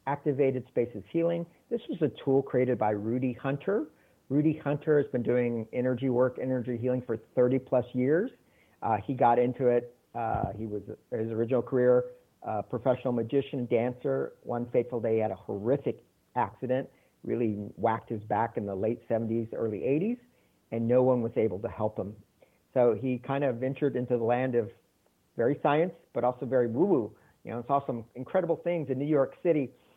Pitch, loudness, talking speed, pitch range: 125 Hz, -29 LUFS, 185 wpm, 115-140 Hz